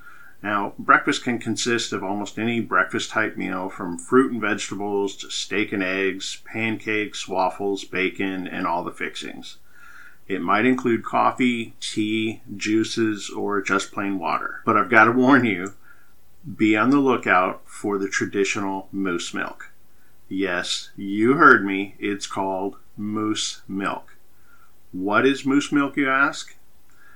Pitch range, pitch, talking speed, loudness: 100-115 Hz, 105 Hz, 140 wpm, -22 LUFS